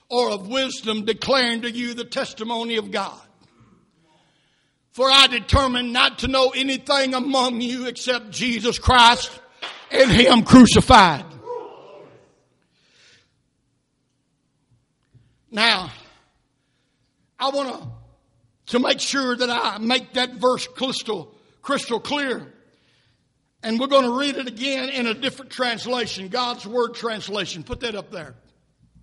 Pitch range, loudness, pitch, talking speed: 195-260 Hz, -19 LUFS, 240 Hz, 120 wpm